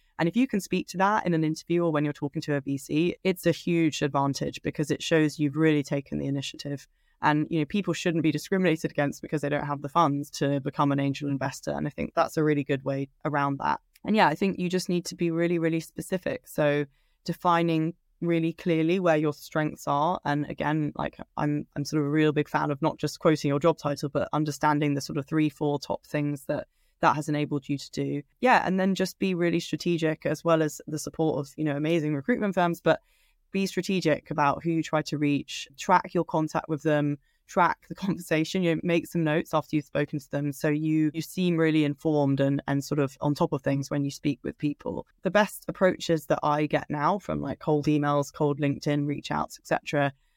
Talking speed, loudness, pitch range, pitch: 230 wpm, -27 LUFS, 145-170 Hz, 155 Hz